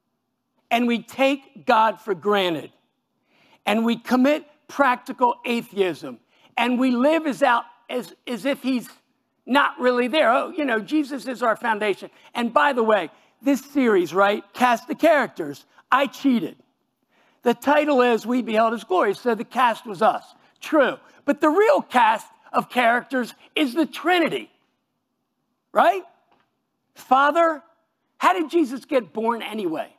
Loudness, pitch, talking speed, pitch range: -21 LUFS, 250 Hz, 145 wpm, 225-295 Hz